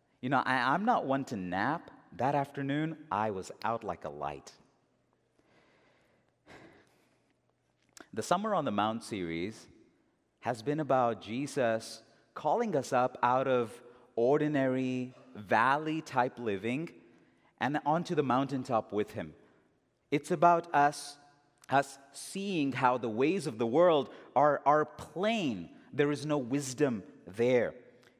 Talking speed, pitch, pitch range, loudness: 125 wpm, 135 Hz, 120-145 Hz, -31 LUFS